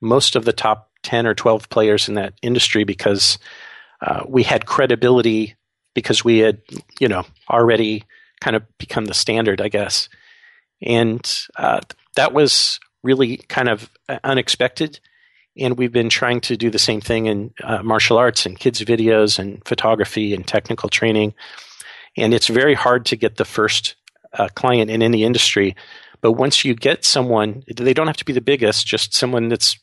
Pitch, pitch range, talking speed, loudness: 115 Hz, 110-120 Hz, 175 wpm, -17 LUFS